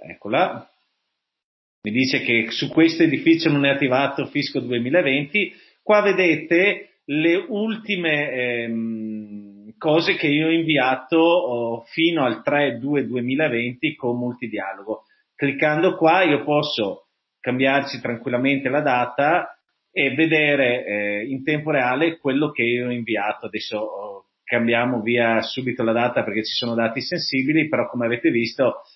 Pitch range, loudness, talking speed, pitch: 120-160 Hz, -20 LUFS, 125 wpm, 140 Hz